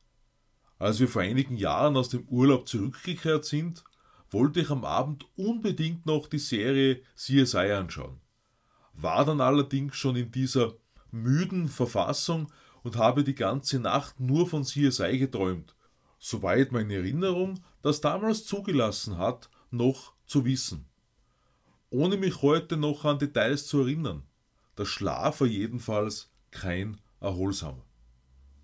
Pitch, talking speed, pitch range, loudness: 130 Hz, 130 wpm, 110-150 Hz, -28 LUFS